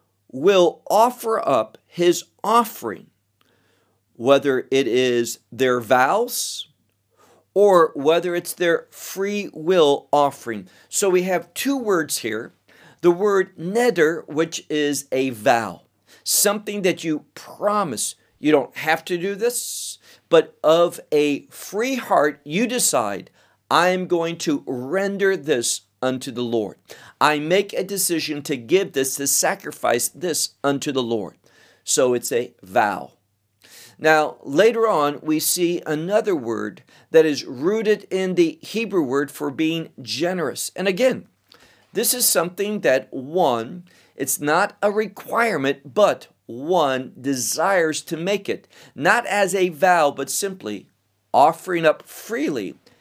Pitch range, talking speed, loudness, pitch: 135-195 Hz, 130 wpm, -20 LUFS, 165 Hz